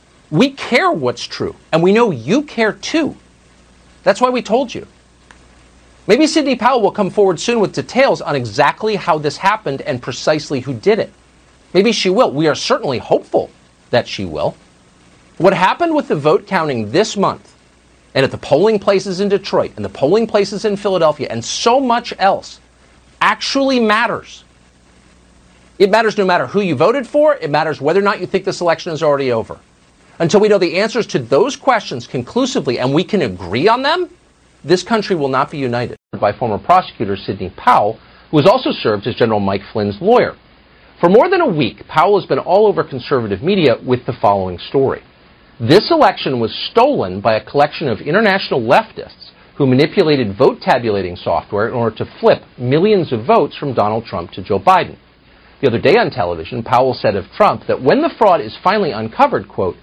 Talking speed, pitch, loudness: 190 wpm, 155 Hz, -15 LUFS